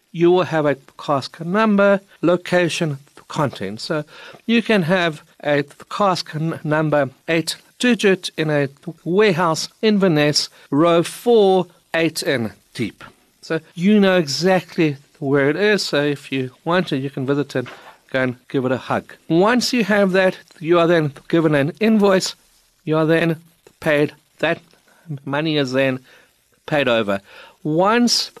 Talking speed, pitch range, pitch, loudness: 145 wpm, 145-185 Hz, 165 Hz, -19 LUFS